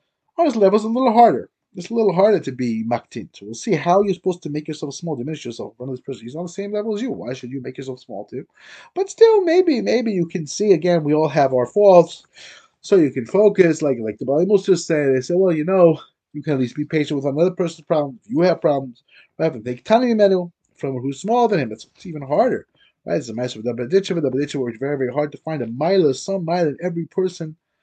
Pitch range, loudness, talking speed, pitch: 135-195 Hz, -19 LUFS, 255 wpm, 165 Hz